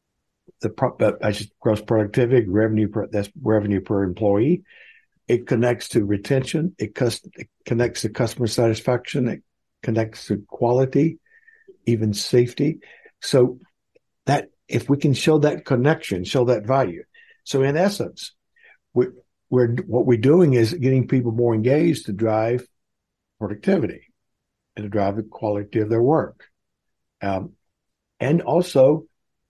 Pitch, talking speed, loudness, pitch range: 120 Hz, 140 wpm, -21 LUFS, 110-145 Hz